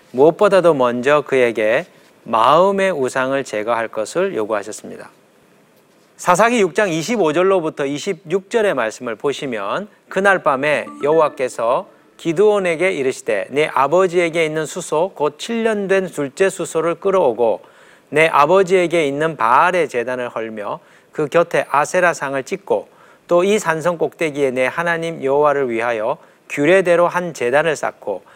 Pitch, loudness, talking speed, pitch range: 165 Hz, -17 LUFS, 295 characters per minute, 140-190 Hz